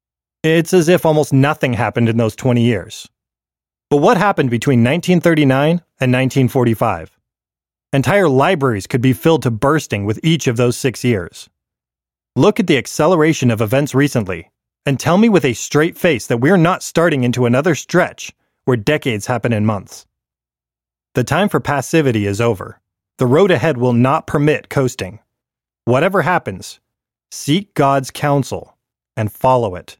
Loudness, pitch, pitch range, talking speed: -15 LUFS, 130 Hz, 115-155 Hz, 155 wpm